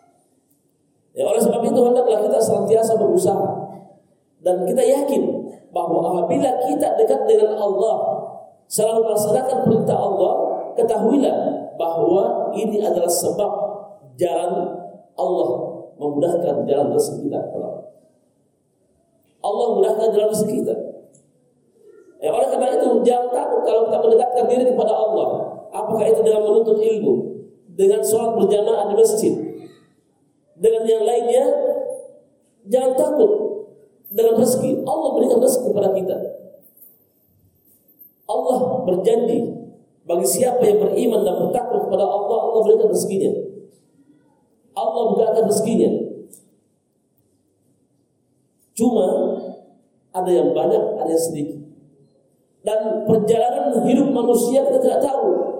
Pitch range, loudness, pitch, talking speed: 200-260 Hz, -19 LUFS, 225 Hz, 110 wpm